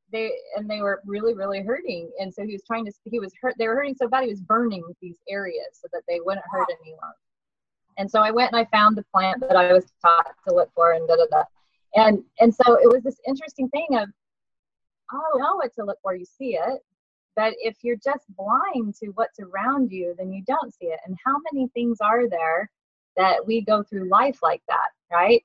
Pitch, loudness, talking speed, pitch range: 215 Hz, -22 LUFS, 230 wpm, 190-250 Hz